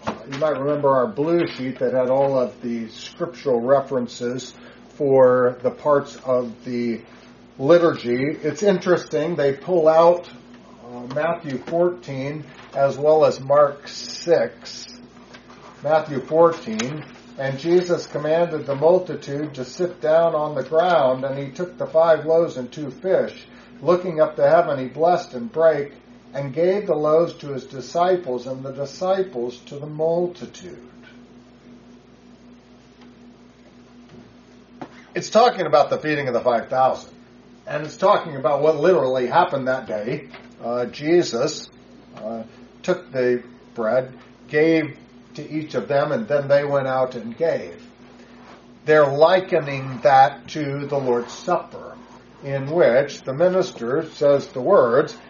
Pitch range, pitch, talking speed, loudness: 125-165 Hz, 140 Hz, 135 wpm, -20 LUFS